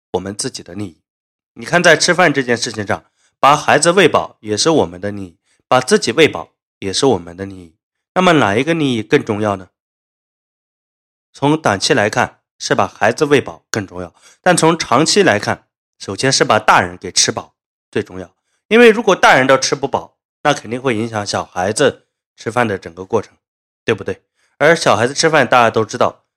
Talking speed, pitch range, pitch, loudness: 280 characters per minute, 95-145 Hz, 115 Hz, -14 LUFS